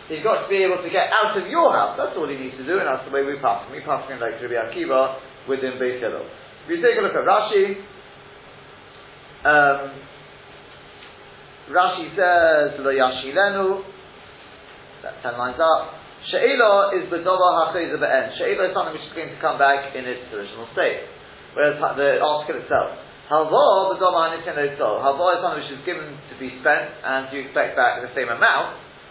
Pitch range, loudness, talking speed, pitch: 135-190 Hz, -20 LUFS, 180 wpm, 150 Hz